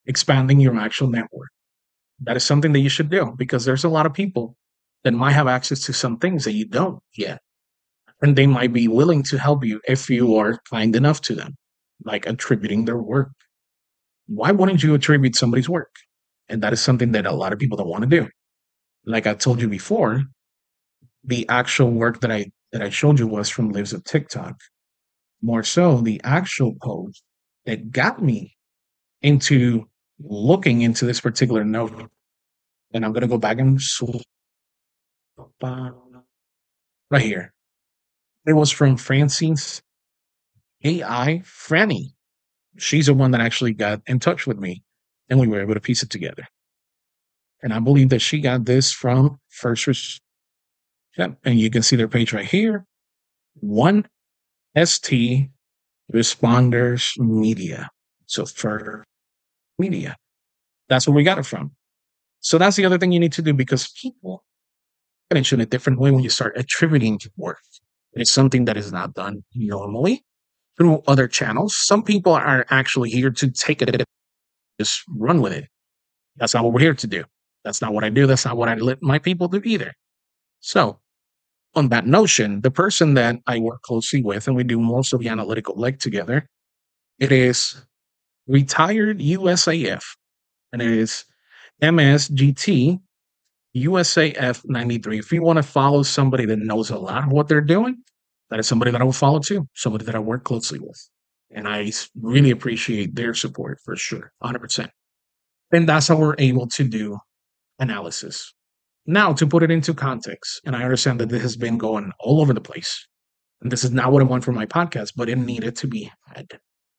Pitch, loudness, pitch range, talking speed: 125 Hz, -19 LUFS, 115-145 Hz, 170 wpm